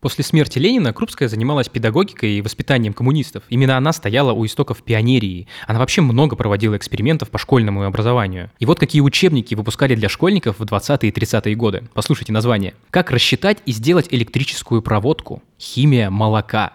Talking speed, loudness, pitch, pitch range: 160 wpm, -17 LUFS, 125 Hz, 110-145 Hz